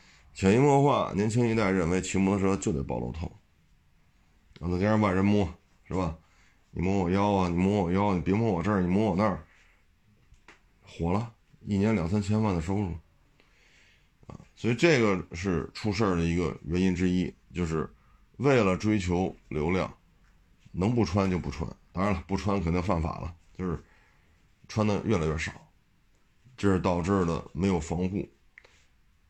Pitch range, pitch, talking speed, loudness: 85-105 Hz, 95 Hz, 245 characters per minute, -28 LUFS